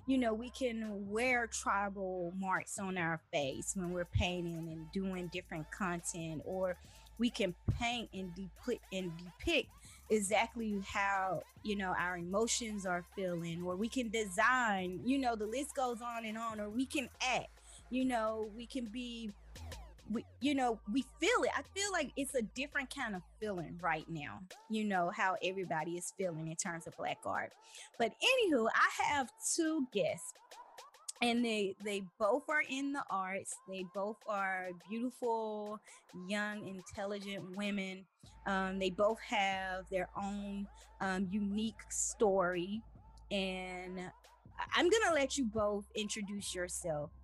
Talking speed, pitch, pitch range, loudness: 155 wpm, 205 Hz, 185-235 Hz, -37 LUFS